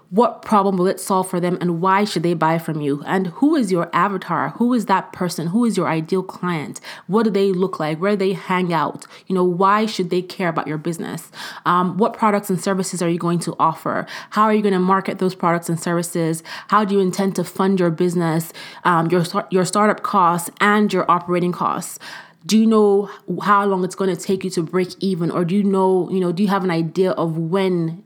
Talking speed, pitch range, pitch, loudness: 235 wpm, 175-200 Hz, 185 Hz, -19 LUFS